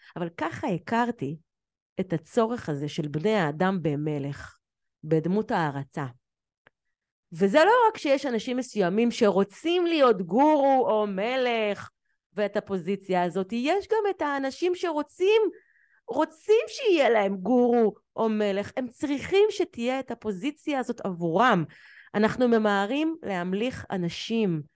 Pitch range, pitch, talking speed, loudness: 185-275 Hz, 220 Hz, 115 wpm, -26 LUFS